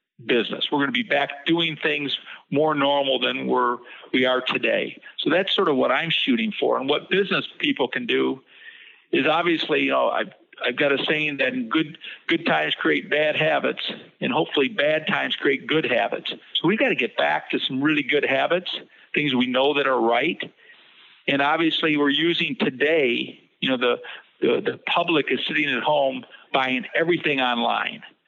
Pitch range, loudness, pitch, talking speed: 140-170 Hz, -22 LUFS, 150 Hz, 185 wpm